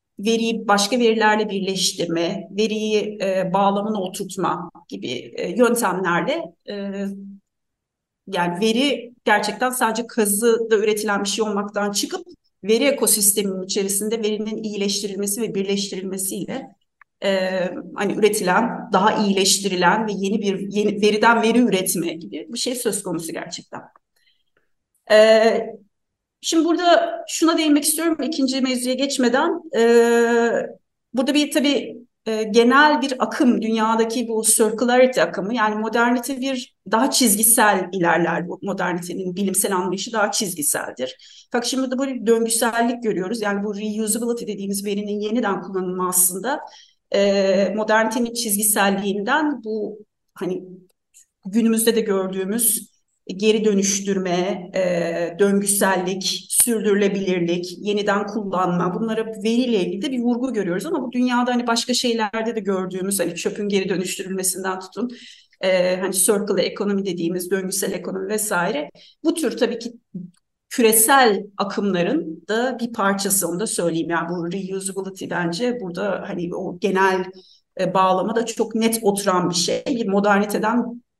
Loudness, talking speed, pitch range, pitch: -20 LUFS, 125 wpm, 190-230 Hz, 210 Hz